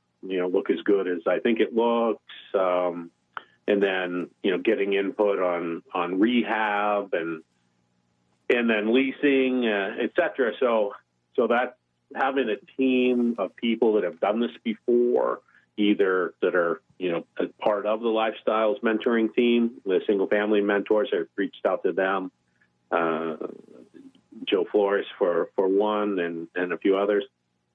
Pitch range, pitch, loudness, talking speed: 90-120 Hz, 105 Hz, -25 LUFS, 155 wpm